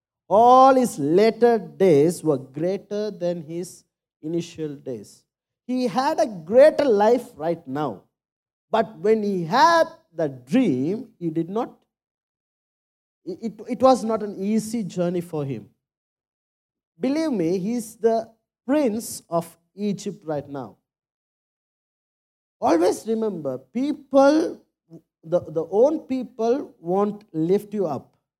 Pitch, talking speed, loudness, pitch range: 205 Hz, 115 wpm, -22 LUFS, 165-245 Hz